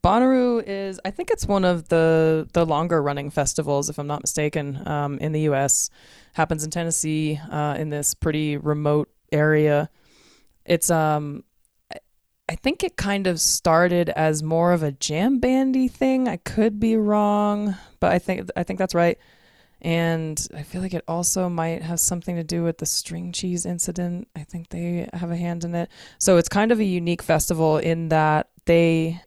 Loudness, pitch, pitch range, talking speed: -22 LUFS, 170 Hz, 155-180 Hz, 185 wpm